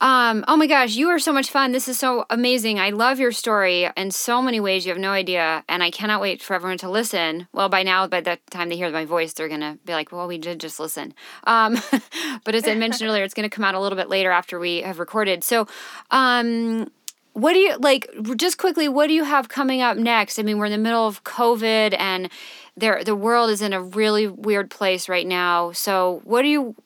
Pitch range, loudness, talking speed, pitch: 185-245 Hz, -20 LUFS, 250 wpm, 215 Hz